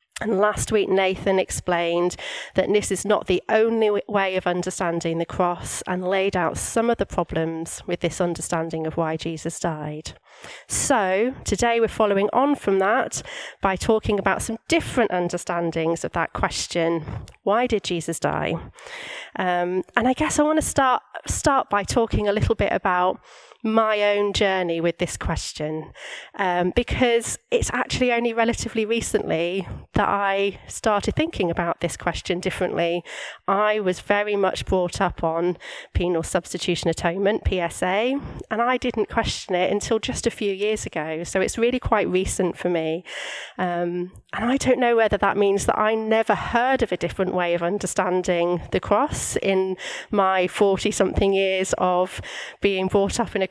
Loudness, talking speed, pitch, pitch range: -23 LUFS, 165 wpm, 190 Hz, 175-220 Hz